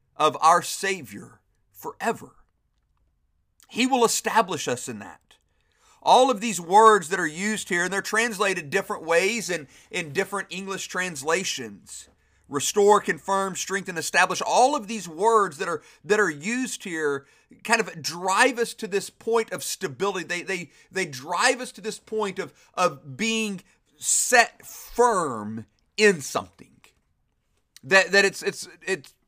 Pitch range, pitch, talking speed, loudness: 175-220 Hz, 195 Hz, 150 wpm, -23 LUFS